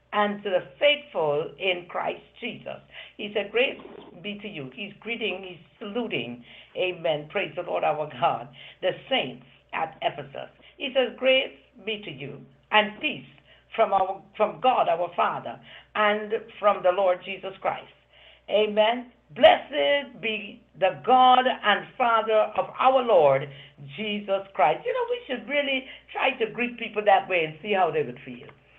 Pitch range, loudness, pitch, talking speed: 180-240 Hz, -25 LUFS, 210 Hz, 160 wpm